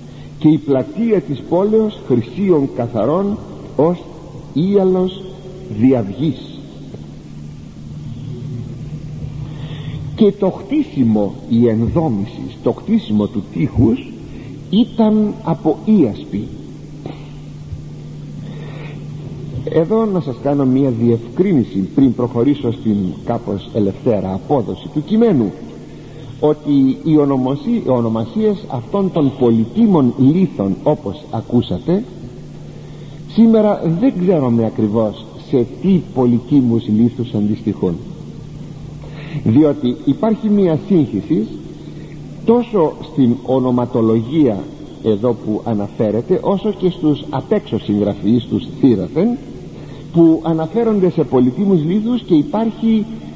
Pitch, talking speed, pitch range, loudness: 145 Hz, 90 wpm, 120-175 Hz, -16 LUFS